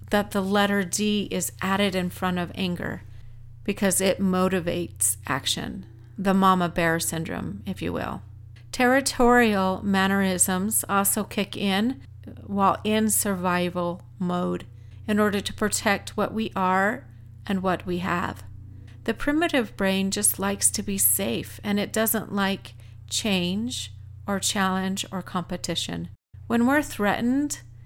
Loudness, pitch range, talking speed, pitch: -24 LUFS, 160-205 Hz, 130 wpm, 190 Hz